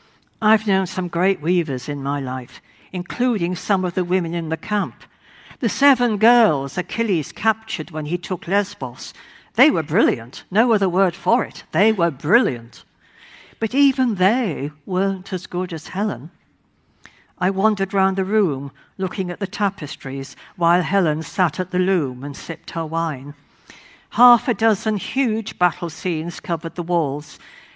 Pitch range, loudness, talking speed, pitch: 165-210 Hz, -20 LUFS, 155 wpm, 185 Hz